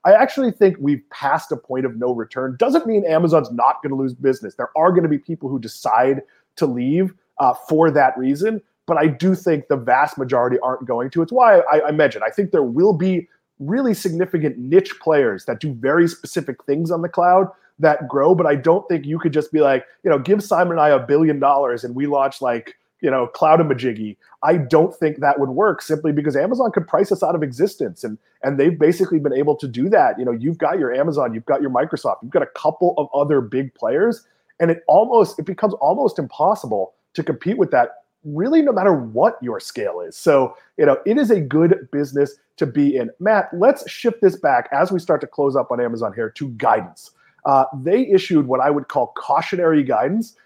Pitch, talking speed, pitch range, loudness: 155 Hz, 225 wpm, 135-185 Hz, -18 LUFS